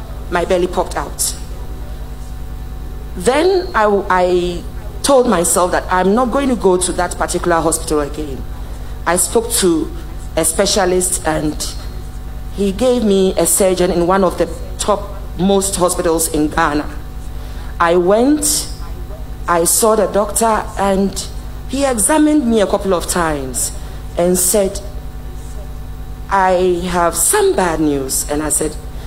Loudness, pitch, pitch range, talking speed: -15 LUFS, 180 Hz, 165-205 Hz, 130 wpm